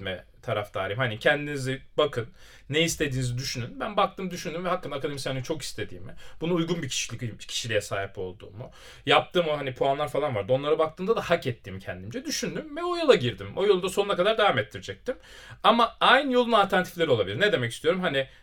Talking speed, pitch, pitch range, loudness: 180 wpm, 145 Hz, 120-180 Hz, -26 LUFS